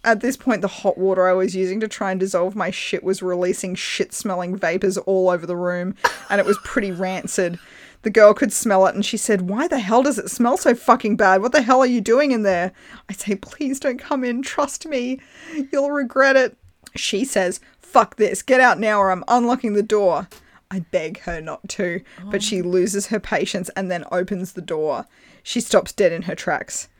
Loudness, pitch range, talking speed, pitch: -20 LUFS, 185-245 Hz, 220 wpm, 200 Hz